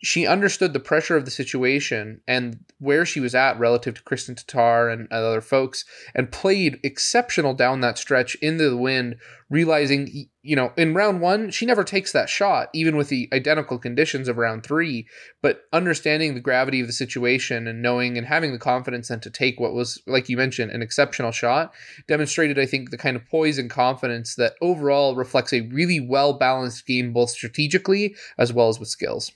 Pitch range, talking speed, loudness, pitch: 120-150 Hz, 190 wpm, -22 LUFS, 130 Hz